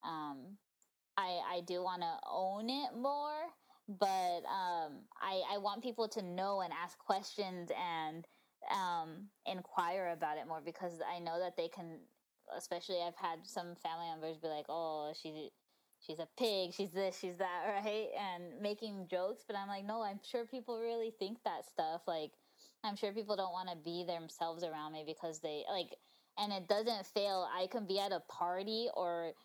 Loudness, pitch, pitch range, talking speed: -41 LUFS, 185 Hz, 170-210 Hz, 175 wpm